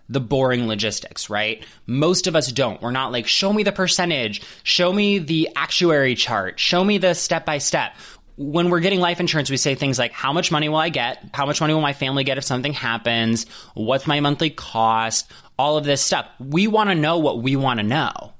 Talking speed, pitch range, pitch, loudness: 220 wpm, 120-170 Hz, 140 Hz, -20 LUFS